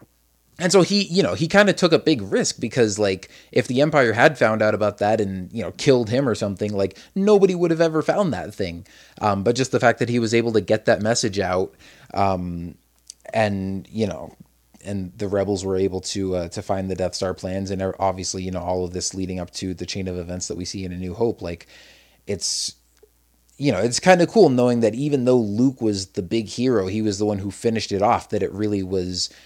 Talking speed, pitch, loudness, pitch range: 240 wpm, 100 Hz, -21 LUFS, 95-120 Hz